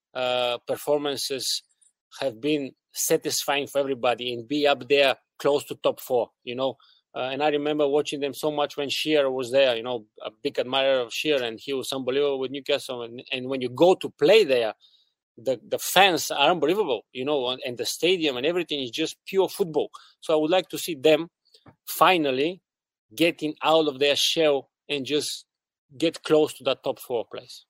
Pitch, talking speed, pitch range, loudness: 145 Hz, 195 wpm, 135-155 Hz, -24 LUFS